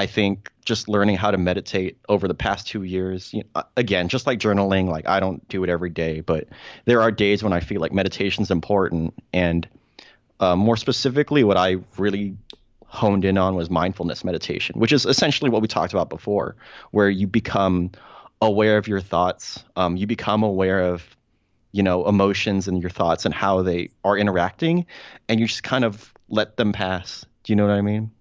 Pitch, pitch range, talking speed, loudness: 100 Hz, 95-110 Hz, 200 wpm, -21 LUFS